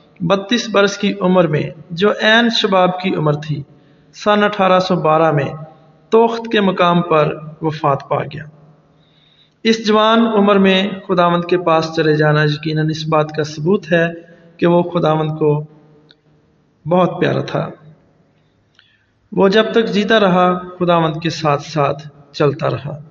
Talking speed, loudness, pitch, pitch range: 145 wpm, -15 LUFS, 165 Hz, 150-190 Hz